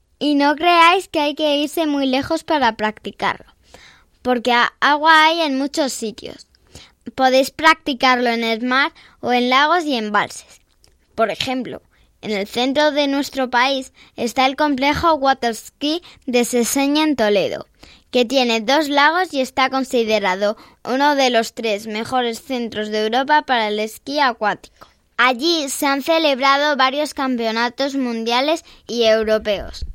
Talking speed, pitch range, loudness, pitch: 140 wpm, 230-290 Hz, -17 LUFS, 260 Hz